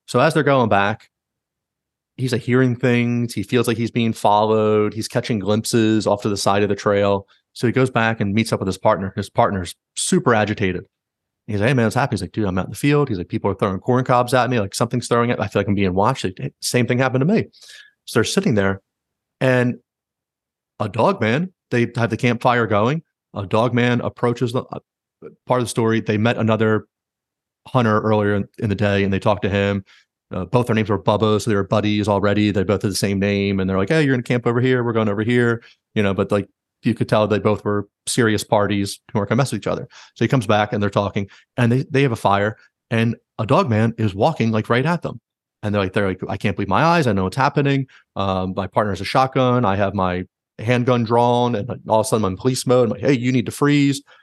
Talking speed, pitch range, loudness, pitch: 250 wpm, 100-125 Hz, -19 LUFS, 110 Hz